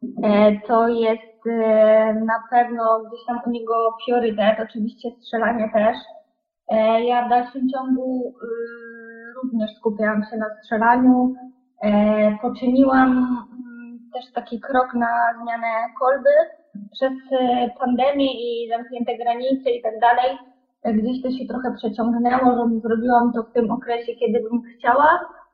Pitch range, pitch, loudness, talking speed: 225-250 Hz, 235 Hz, -20 LUFS, 115 wpm